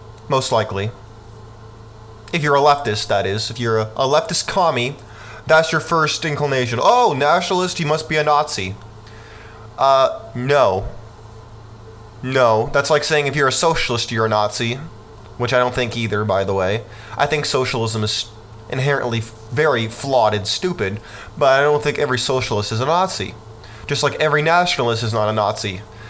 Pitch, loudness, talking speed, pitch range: 115 Hz, -18 LUFS, 165 wpm, 110-145 Hz